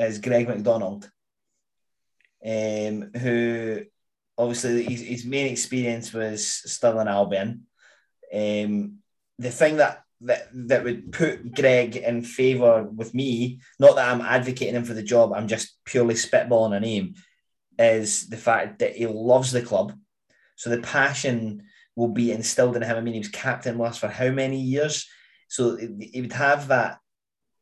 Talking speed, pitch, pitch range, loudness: 155 wpm, 120 Hz, 110-125 Hz, -23 LUFS